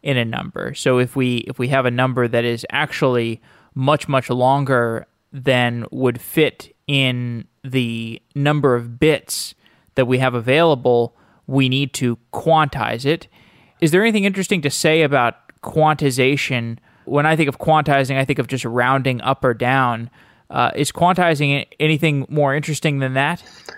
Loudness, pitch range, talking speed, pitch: -18 LUFS, 125-150 Hz, 160 wpm, 135 Hz